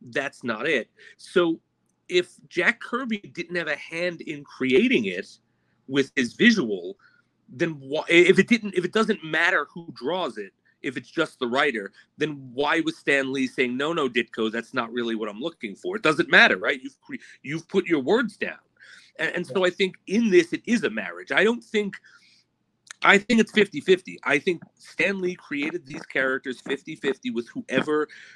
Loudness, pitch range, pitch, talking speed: -24 LUFS, 145-220 Hz, 180 Hz, 190 wpm